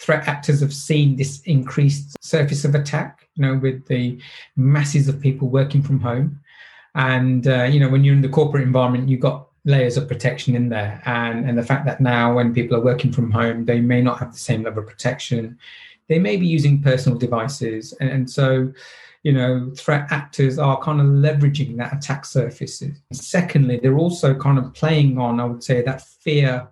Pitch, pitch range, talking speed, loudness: 135 Hz, 125-145 Hz, 200 wpm, -19 LUFS